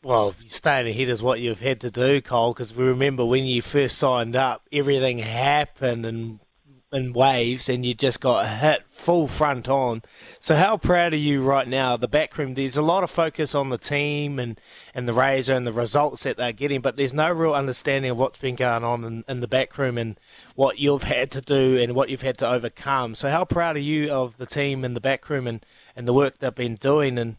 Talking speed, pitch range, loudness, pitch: 230 wpm, 120-140 Hz, -23 LUFS, 130 Hz